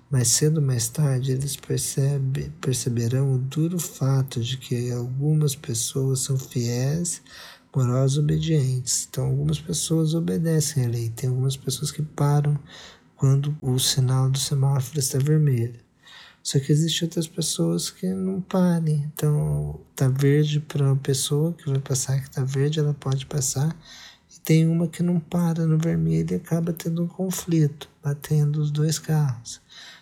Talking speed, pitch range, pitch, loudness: 150 wpm, 130-155 Hz, 145 Hz, -24 LUFS